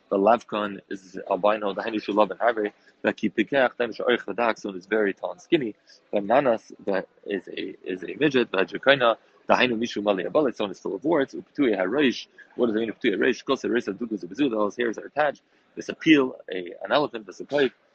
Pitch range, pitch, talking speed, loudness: 100-115 Hz, 105 Hz, 230 wpm, -25 LUFS